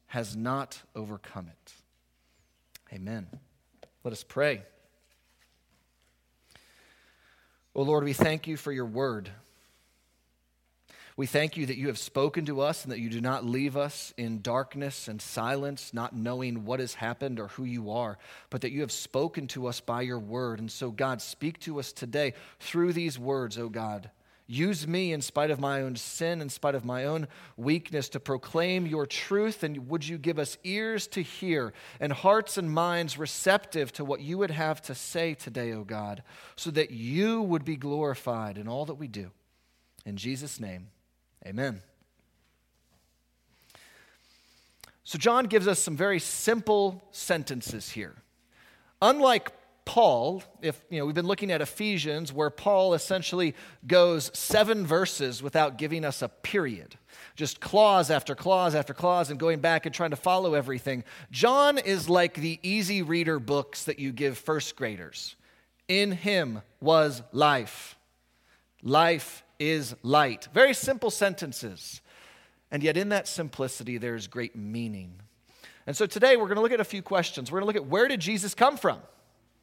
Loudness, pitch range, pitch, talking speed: -28 LUFS, 115-170 Hz, 145 Hz, 165 wpm